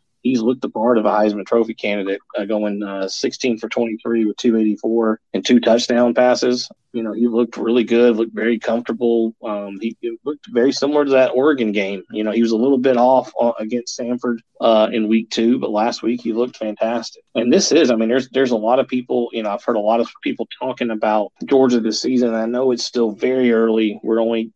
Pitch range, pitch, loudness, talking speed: 110-125 Hz, 115 Hz, -18 LUFS, 225 wpm